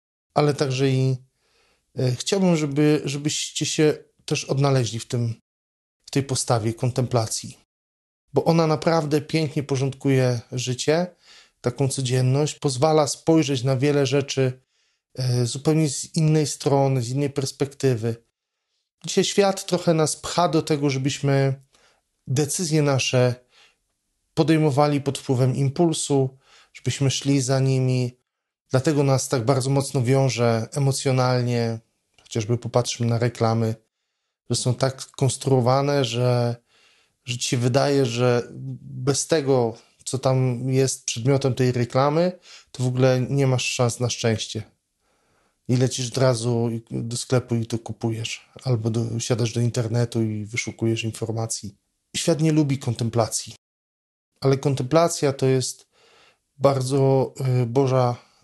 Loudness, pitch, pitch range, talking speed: -22 LUFS, 130 Hz, 120-140 Hz, 125 wpm